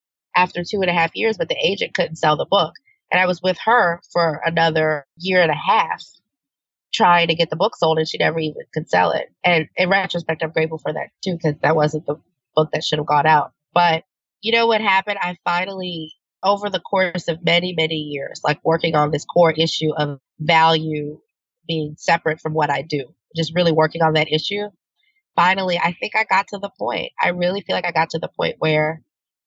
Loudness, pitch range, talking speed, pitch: -19 LUFS, 155-185 Hz, 220 wpm, 165 Hz